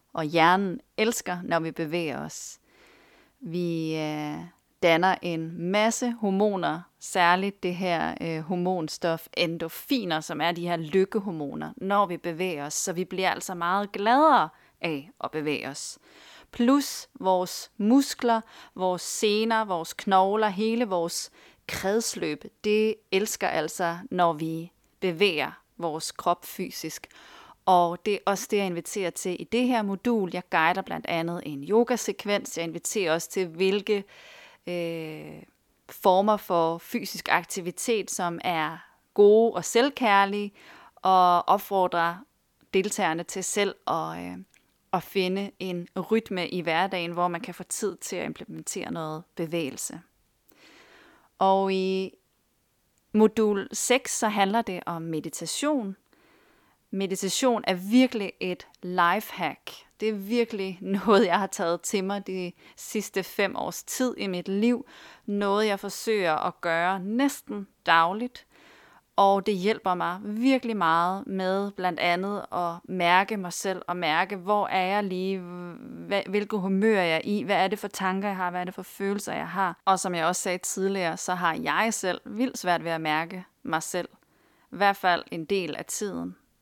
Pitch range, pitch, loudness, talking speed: 175-210 Hz, 190 Hz, -26 LUFS, 145 wpm